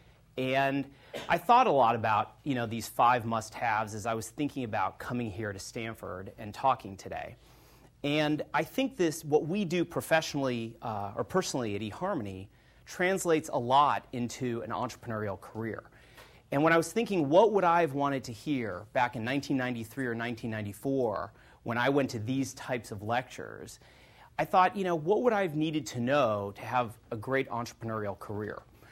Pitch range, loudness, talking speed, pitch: 110-145 Hz, -30 LUFS, 175 wpm, 125 Hz